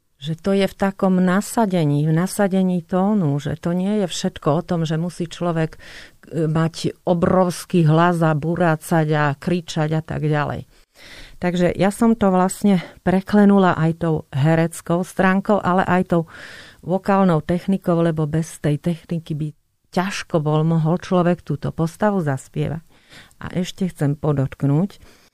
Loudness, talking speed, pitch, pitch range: -20 LUFS, 140 wpm, 170 Hz, 155-185 Hz